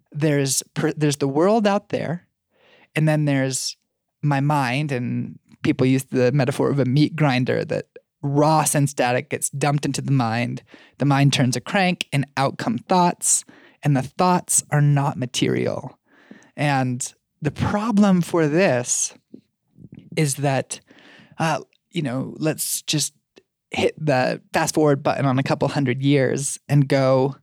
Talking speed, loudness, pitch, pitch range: 150 wpm, -21 LUFS, 145 Hz, 135-155 Hz